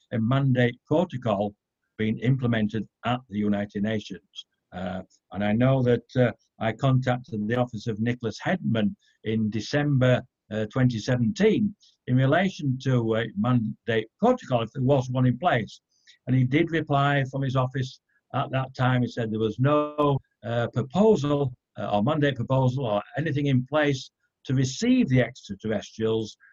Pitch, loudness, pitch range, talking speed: 125 Hz, -25 LUFS, 110-135 Hz, 155 wpm